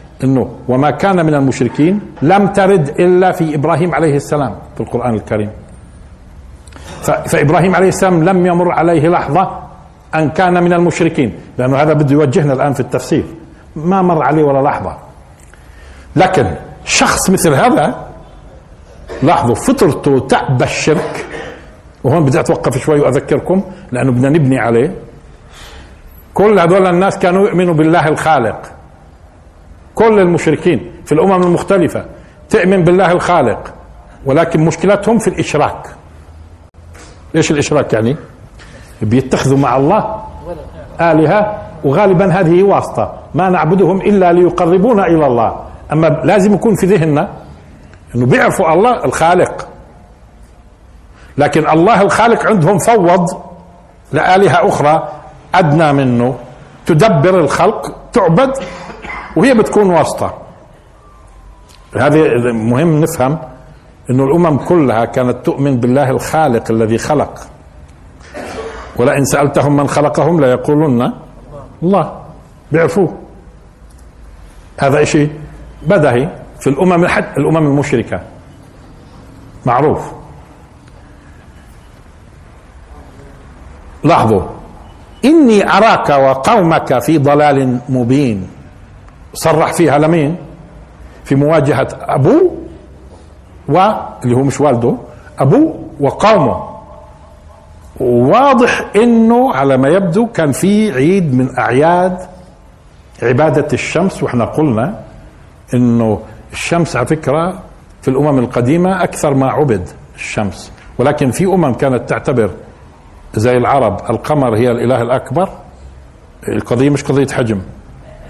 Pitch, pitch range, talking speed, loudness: 145 Hz, 110-170 Hz, 100 wpm, -12 LUFS